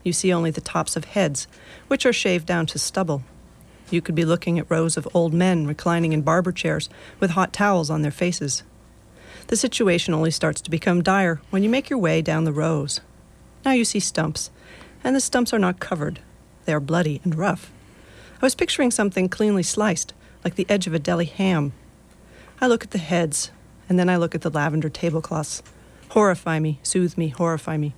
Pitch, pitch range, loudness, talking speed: 170 Hz, 160-195 Hz, -22 LUFS, 200 wpm